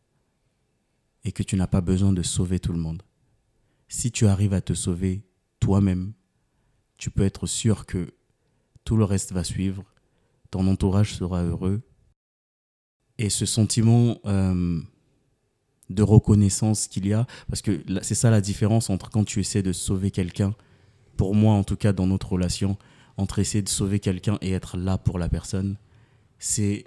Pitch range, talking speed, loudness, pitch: 95-110 Hz, 165 wpm, -24 LUFS, 100 Hz